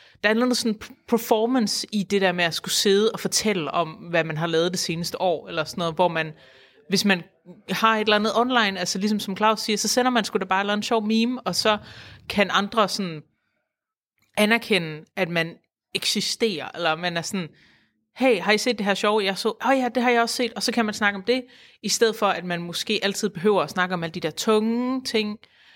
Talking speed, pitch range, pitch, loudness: 235 wpm, 175-225 Hz, 205 Hz, -23 LUFS